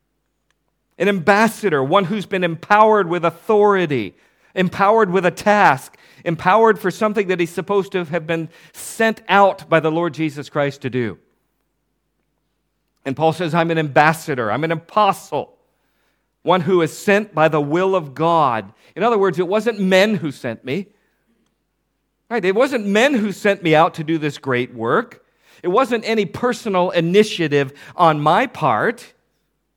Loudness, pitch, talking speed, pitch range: -17 LUFS, 180 Hz, 155 wpm, 160-205 Hz